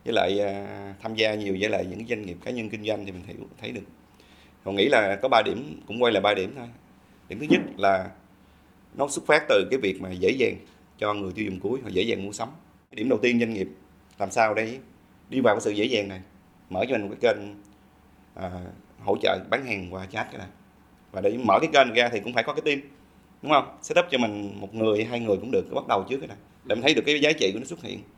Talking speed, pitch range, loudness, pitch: 265 wpm, 95-115 Hz, -25 LUFS, 100 Hz